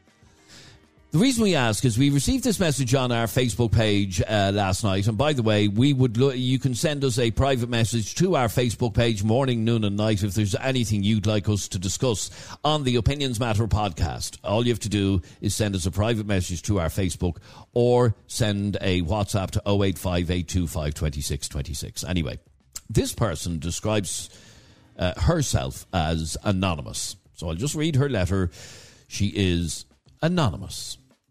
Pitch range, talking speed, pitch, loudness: 95-125 Hz, 170 wpm, 105 Hz, -24 LUFS